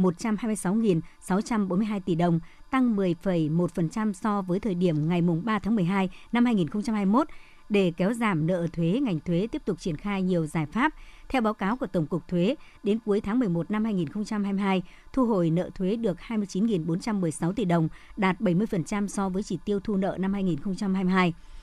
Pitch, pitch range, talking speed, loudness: 195 Hz, 175-215 Hz, 170 wpm, -27 LUFS